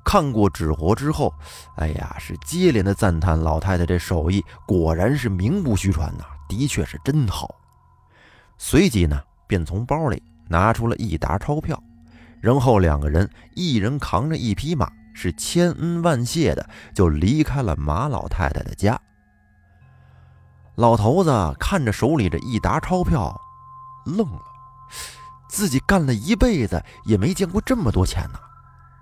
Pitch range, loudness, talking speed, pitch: 85-140 Hz, -21 LUFS, 220 characters per minute, 105 Hz